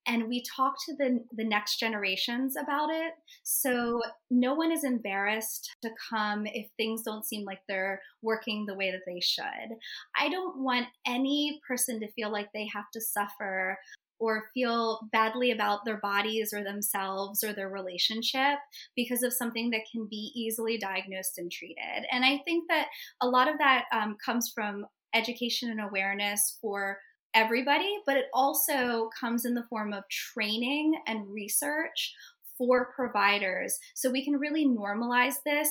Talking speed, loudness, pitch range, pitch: 165 wpm, -30 LUFS, 210-260 Hz, 230 Hz